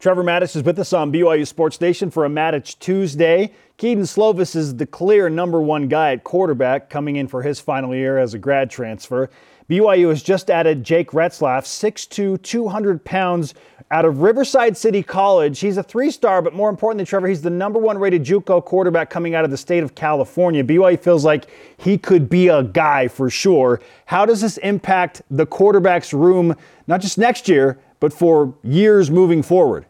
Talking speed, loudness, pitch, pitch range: 190 wpm, -17 LUFS, 175 Hz, 150-195 Hz